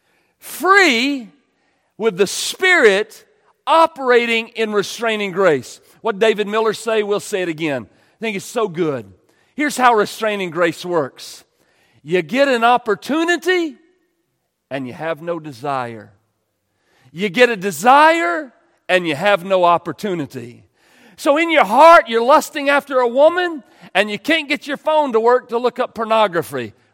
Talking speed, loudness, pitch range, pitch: 145 wpm, -16 LUFS, 175-285 Hz, 225 Hz